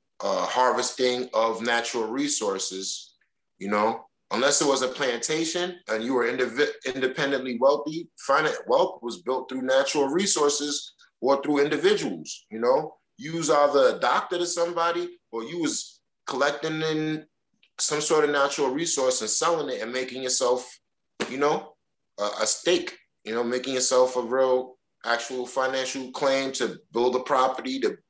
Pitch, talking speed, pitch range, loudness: 130 Hz, 155 wpm, 125-155 Hz, -25 LUFS